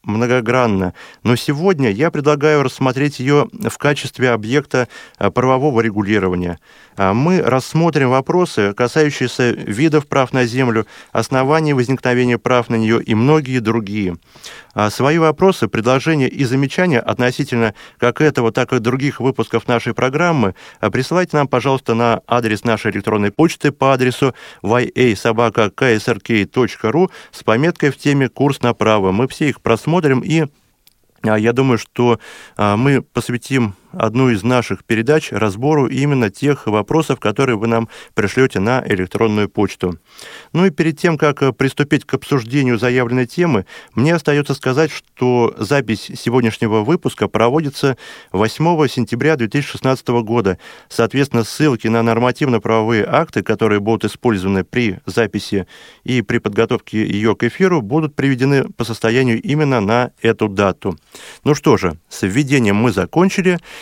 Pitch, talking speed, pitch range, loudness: 125 Hz, 130 wpm, 110-140 Hz, -16 LUFS